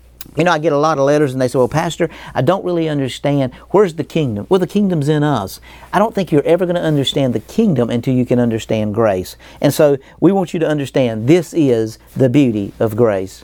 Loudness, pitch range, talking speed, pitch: -16 LUFS, 120-165 Hz, 235 wpm, 140 Hz